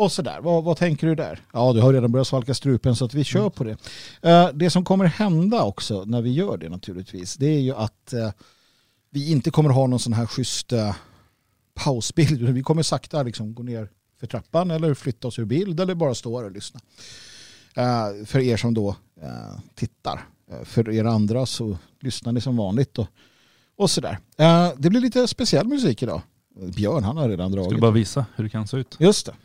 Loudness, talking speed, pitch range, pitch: -22 LUFS, 200 wpm, 110-155 Hz, 125 Hz